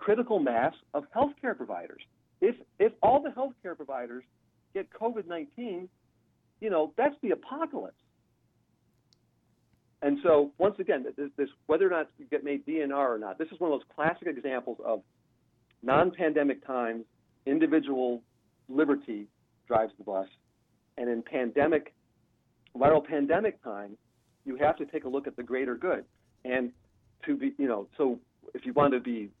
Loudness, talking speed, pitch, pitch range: -30 LUFS, 155 wpm, 145 Hz, 120-180 Hz